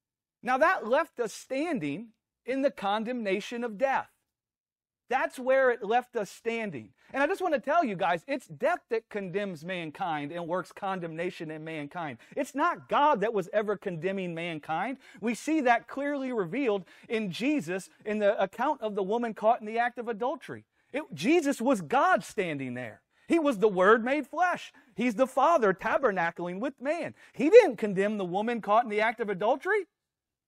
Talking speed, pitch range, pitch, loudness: 175 wpm, 195-275 Hz, 225 Hz, -29 LUFS